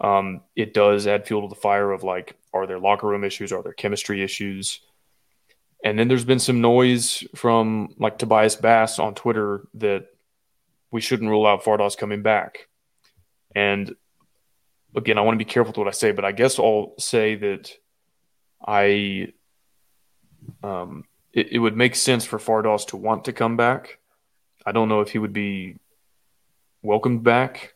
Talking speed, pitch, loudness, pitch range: 170 wpm, 105 Hz, -21 LUFS, 100-115 Hz